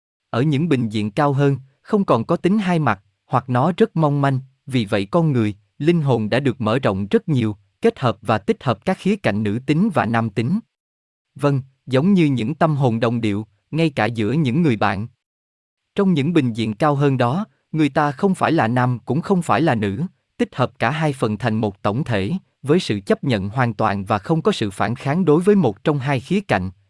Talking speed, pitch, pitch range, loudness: 230 wpm, 130 Hz, 110-160 Hz, -20 LUFS